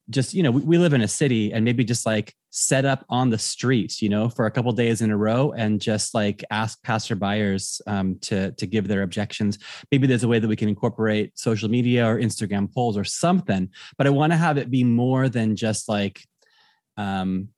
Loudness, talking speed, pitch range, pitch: -22 LUFS, 220 wpm, 105-125 Hz, 110 Hz